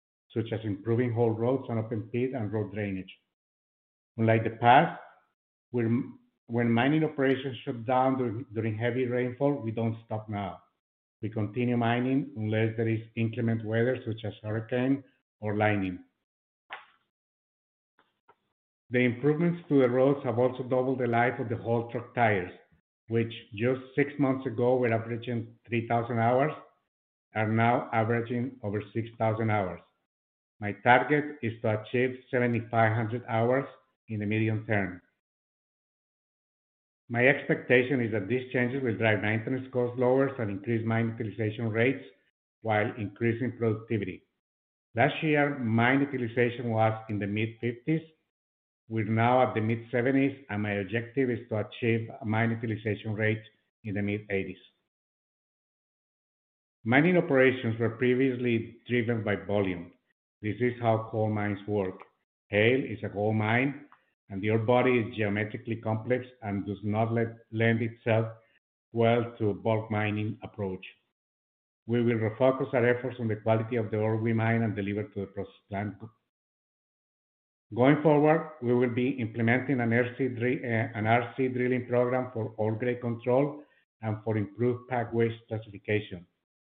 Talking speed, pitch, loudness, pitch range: 140 wpm, 115 Hz, -29 LUFS, 110-125 Hz